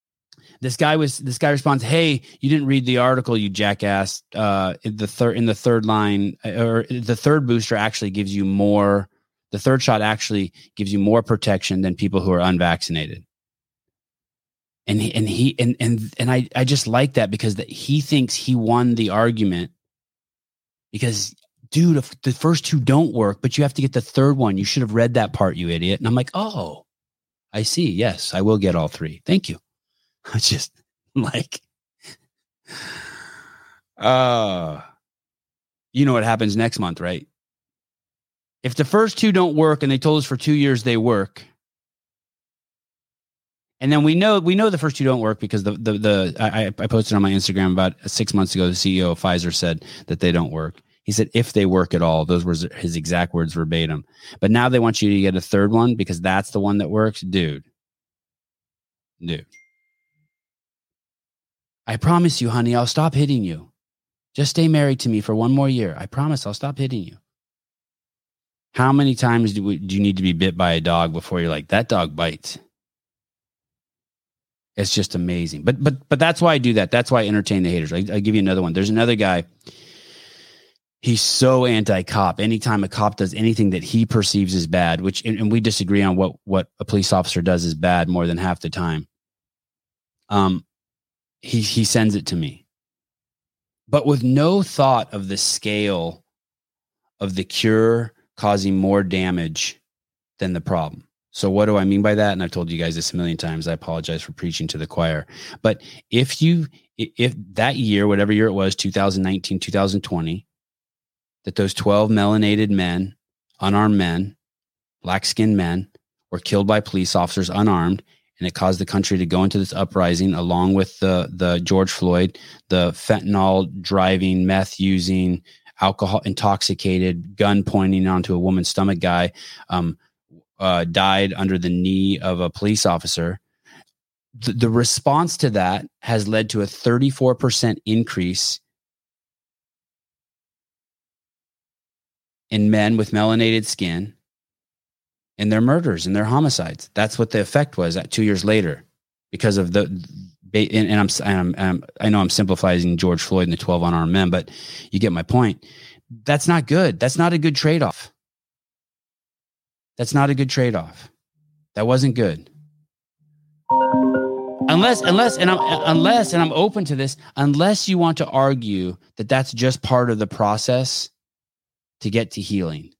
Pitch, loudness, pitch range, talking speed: 105 Hz, -19 LUFS, 95-125 Hz, 175 wpm